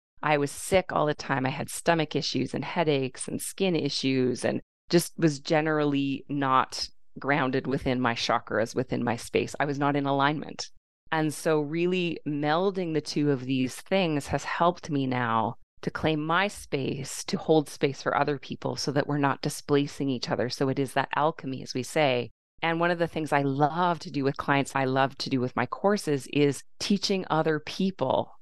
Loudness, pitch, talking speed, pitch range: -27 LUFS, 145 Hz, 195 wpm, 135-160 Hz